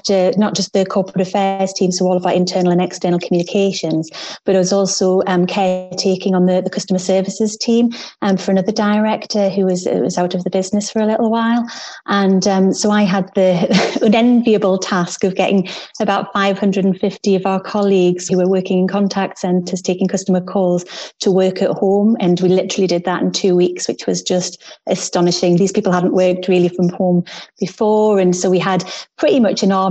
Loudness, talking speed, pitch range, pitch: -16 LUFS, 200 wpm, 185-200 Hz, 190 Hz